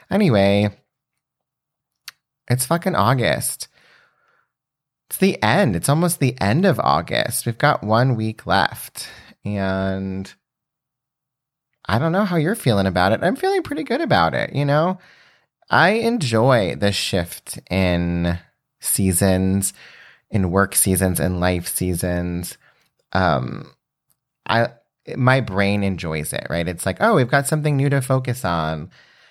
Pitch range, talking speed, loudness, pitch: 95-140 Hz, 130 wpm, -19 LUFS, 105 Hz